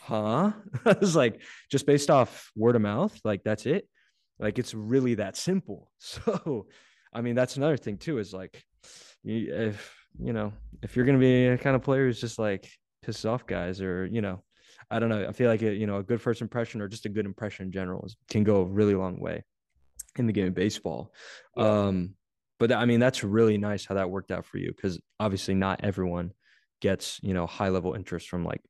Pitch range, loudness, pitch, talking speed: 95-120 Hz, -28 LUFS, 105 Hz, 215 wpm